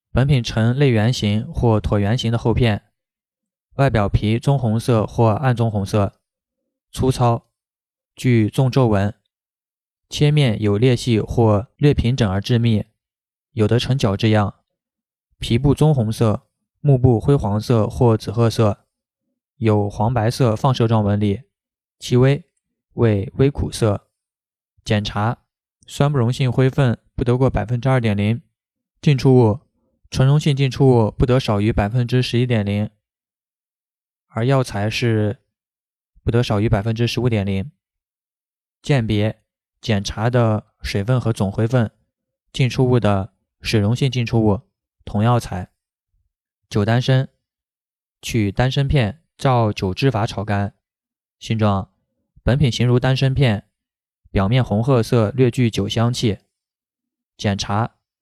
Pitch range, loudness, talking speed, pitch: 105-130 Hz, -19 LUFS, 195 characters per minute, 115 Hz